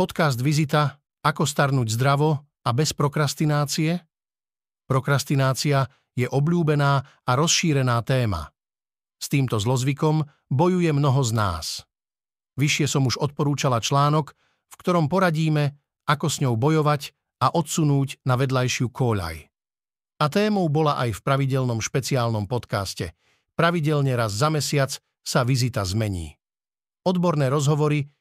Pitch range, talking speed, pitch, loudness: 125-155 Hz, 115 wpm, 140 Hz, -23 LUFS